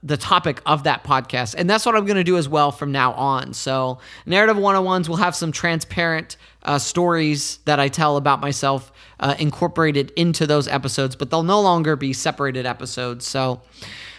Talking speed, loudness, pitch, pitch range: 185 wpm, -20 LUFS, 145 Hz, 135-170 Hz